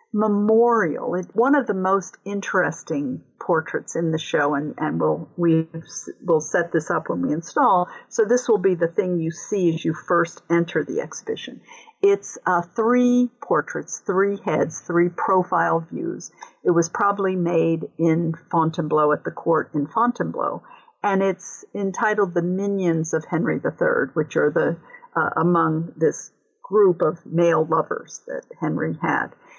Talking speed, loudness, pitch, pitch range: 155 wpm, -22 LUFS, 185 Hz, 165-235 Hz